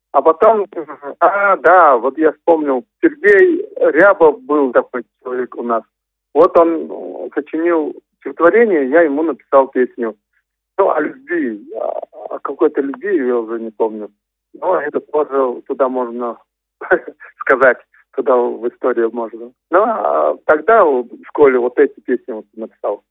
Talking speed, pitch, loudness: 130 wpm, 150 Hz, -15 LUFS